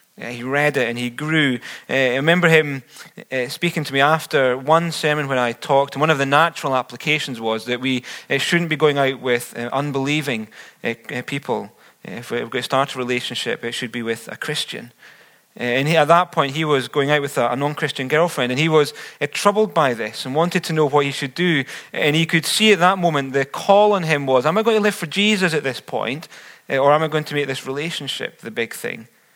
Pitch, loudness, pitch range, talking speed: 145 Hz, -19 LUFS, 130-160 Hz, 220 wpm